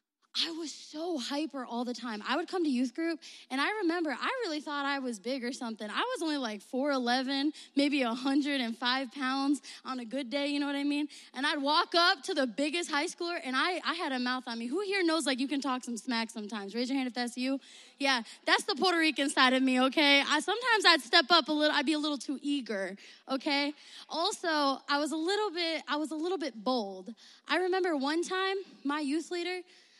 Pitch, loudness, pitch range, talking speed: 285 Hz, -30 LUFS, 260-325 Hz, 230 wpm